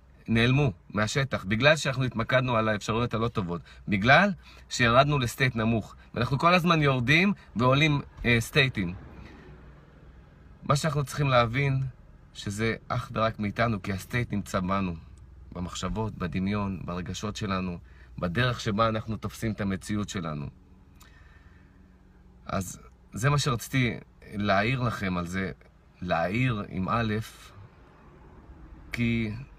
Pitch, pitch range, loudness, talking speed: 110 Hz, 90-125 Hz, -27 LUFS, 110 wpm